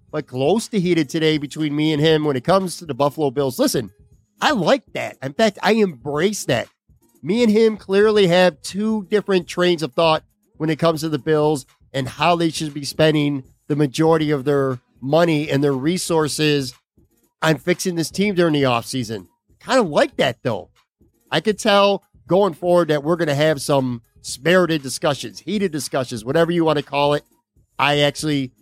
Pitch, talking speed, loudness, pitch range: 155 Hz, 190 wpm, -19 LUFS, 145-175 Hz